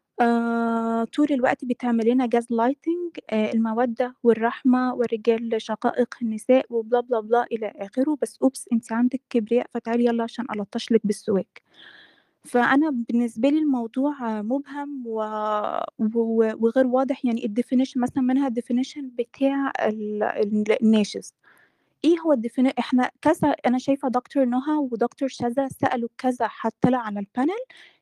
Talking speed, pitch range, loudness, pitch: 125 wpm, 230-265 Hz, -24 LUFS, 245 Hz